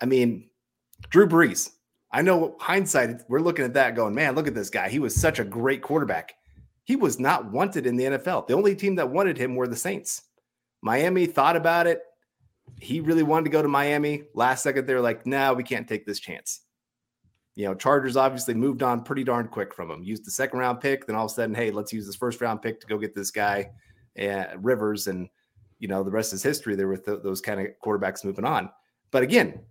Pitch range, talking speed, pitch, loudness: 105-140 Hz, 230 wpm, 125 Hz, -25 LUFS